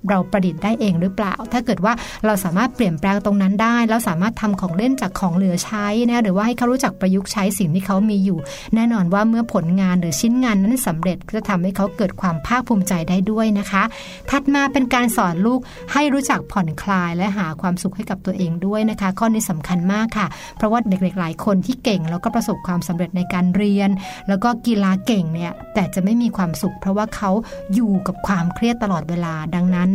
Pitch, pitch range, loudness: 200 Hz, 185-225 Hz, -19 LUFS